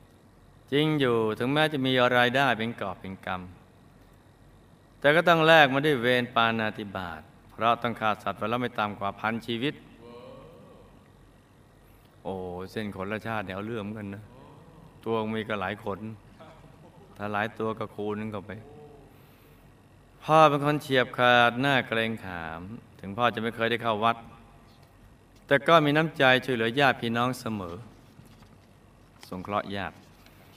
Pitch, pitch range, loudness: 115 Hz, 105-125 Hz, -26 LUFS